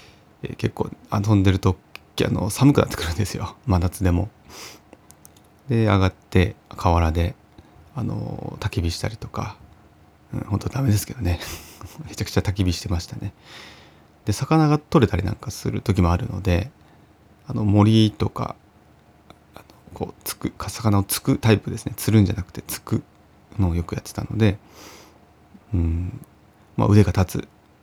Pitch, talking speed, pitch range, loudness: 105 Hz, 290 characters per minute, 90-110 Hz, -22 LUFS